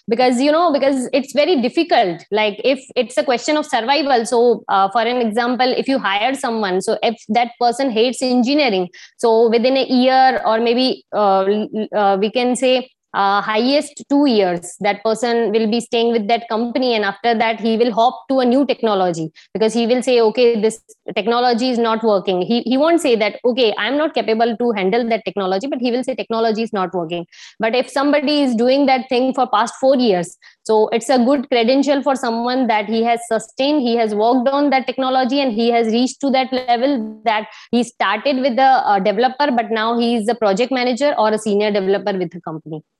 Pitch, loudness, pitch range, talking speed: 235 Hz, -17 LUFS, 220-260 Hz, 210 wpm